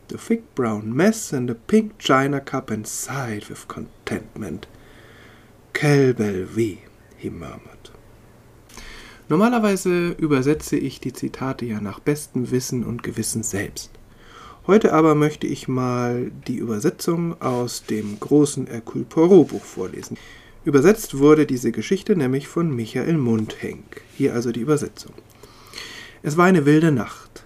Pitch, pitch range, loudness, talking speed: 125 Hz, 110-150 Hz, -21 LUFS, 125 wpm